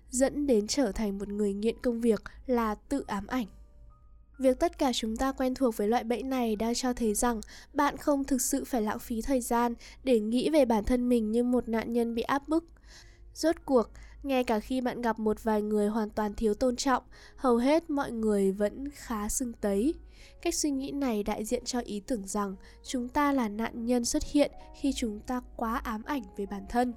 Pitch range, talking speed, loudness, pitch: 220-270 Hz, 220 wpm, -30 LUFS, 245 Hz